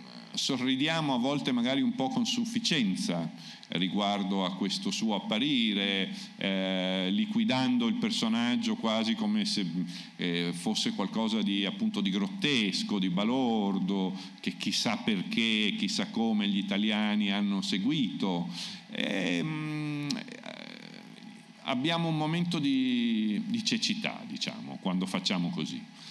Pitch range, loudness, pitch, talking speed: 170-230 Hz, -30 LUFS, 215 Hz, 115 wpm